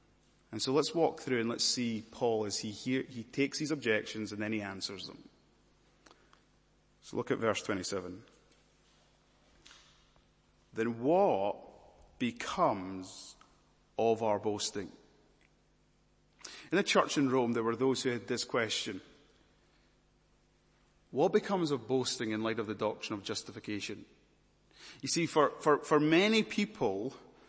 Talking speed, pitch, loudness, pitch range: 135 wpm, 115 Hz, -33 LUFS, 105-140 Hz